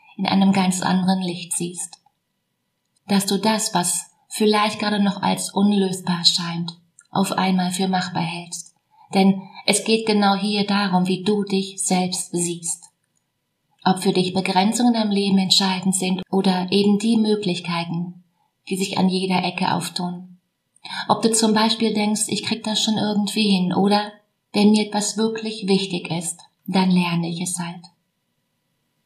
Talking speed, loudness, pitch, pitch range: 150 wpm, -20 LUFS, 190 Hz, 180-205 Hz